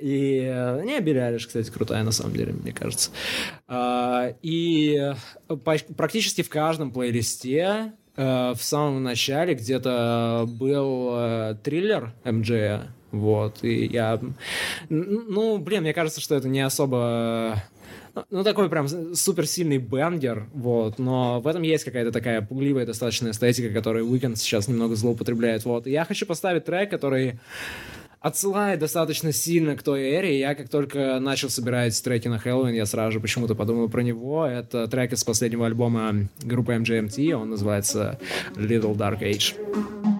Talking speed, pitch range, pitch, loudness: 145 wpm, 115-155 Hz, 125 Hz, -25 LUFS